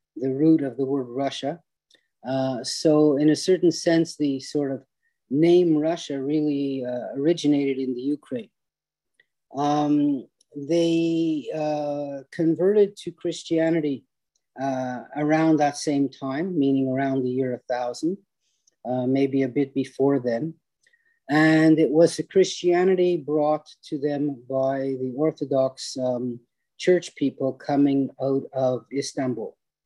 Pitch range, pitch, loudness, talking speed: 135-160 Hz, 145 Hz, -23 LUFS, 125 wpm